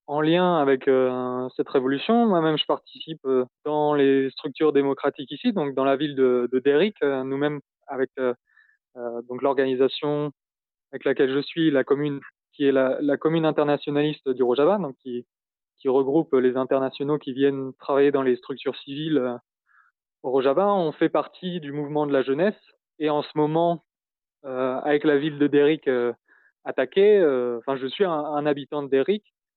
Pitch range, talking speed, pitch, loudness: 135-155 Hz, 175 wpm, 140 Hz, -23 LUFS